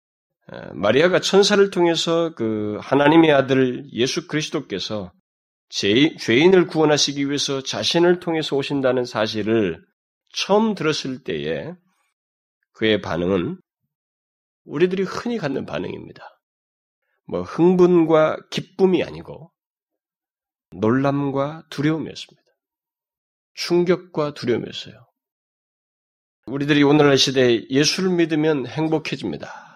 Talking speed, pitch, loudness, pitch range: 255 characters per minute, 150 Hz, -19 LUFS, 125-170 Hz